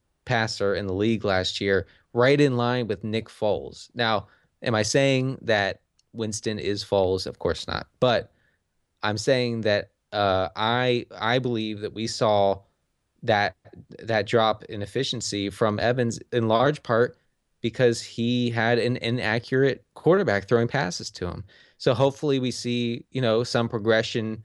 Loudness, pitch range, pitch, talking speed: -25 LUFS, 100-120 Hz, 115 Hz, 150 wpm